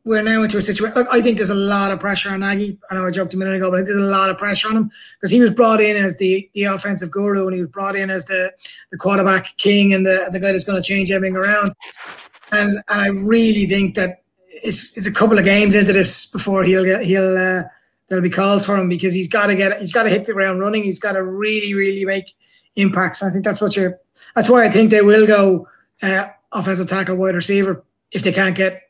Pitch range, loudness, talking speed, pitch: 190-205 Hz, -16 LUFS, 255 wpm, 195 Hz